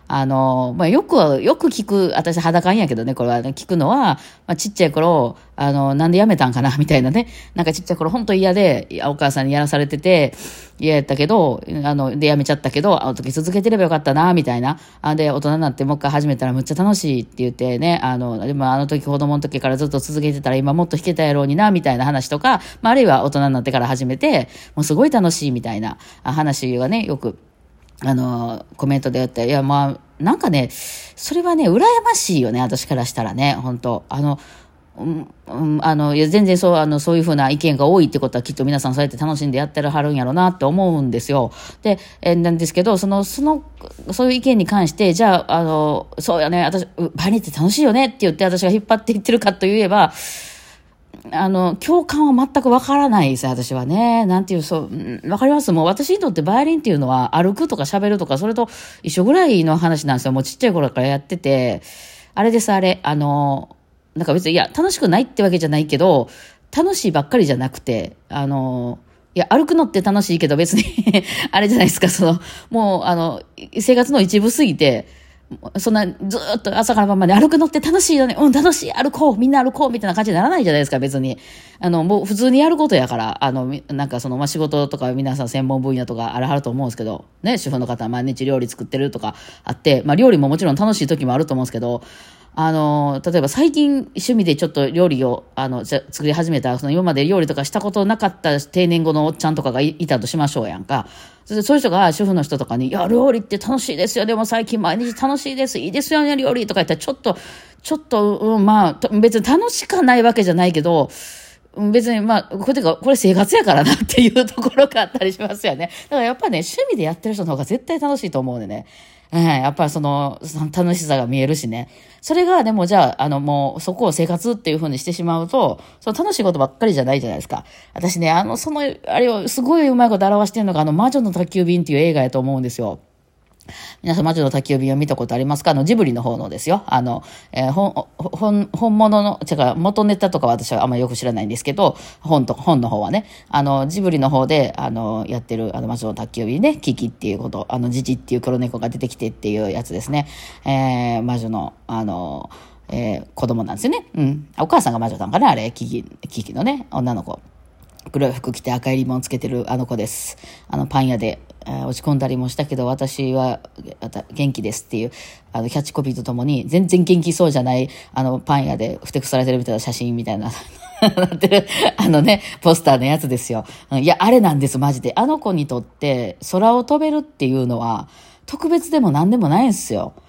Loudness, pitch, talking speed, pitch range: -17 LUFS, 155 Hz, 445 characters per minute, 130-205 Hz